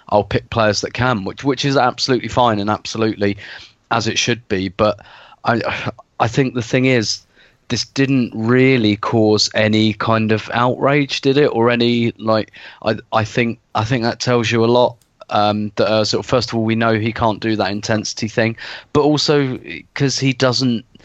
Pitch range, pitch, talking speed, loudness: 110-125 Hz, 115 Hz, 190 wpm, -17 LUFS